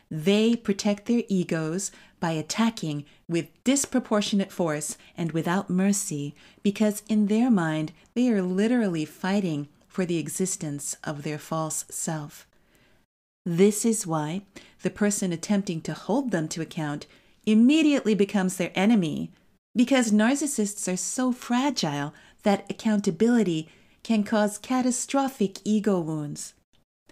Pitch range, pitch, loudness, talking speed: 165-220 Hz, 195 Hz, -26 LUFS, 120 wpm